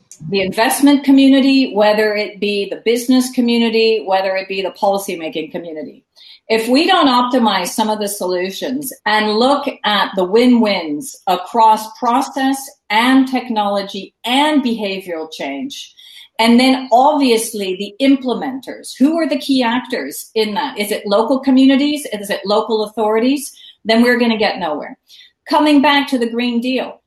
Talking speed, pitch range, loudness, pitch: 150 wpm, 205-270 Hz, -15 LUFS, 235 Hz